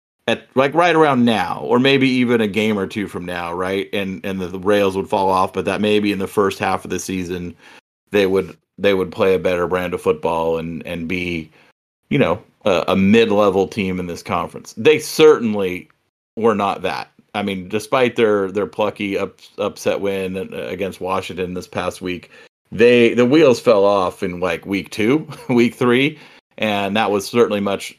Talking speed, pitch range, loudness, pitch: 195 wpm, 95-120 Hz, -18 LUFS, 100 Hz